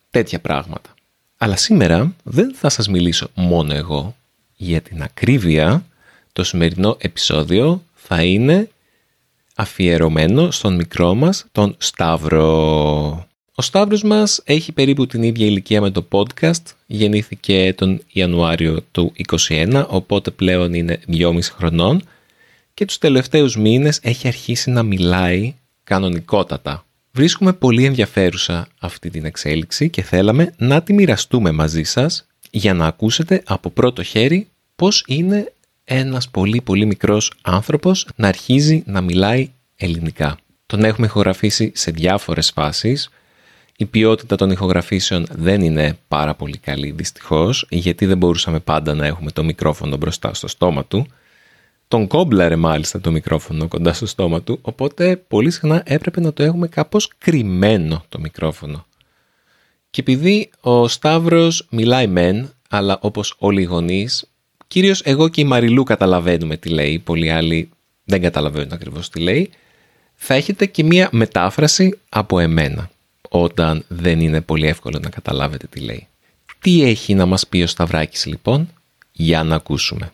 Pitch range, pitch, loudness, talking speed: 85-135 Hz, 100 Hz, -16 LUFS, 140 wpm